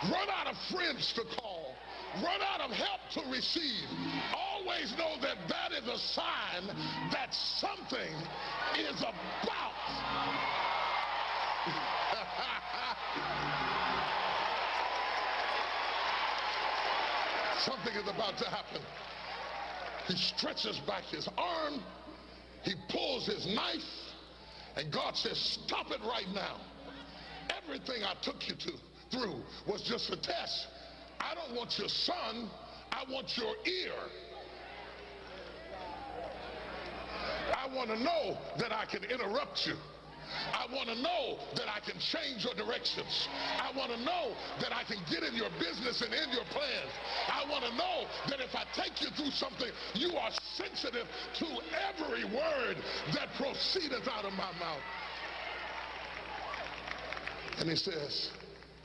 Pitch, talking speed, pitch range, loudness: 275 Hz, 125 wpm, 240-330 Hz, -36 LUFS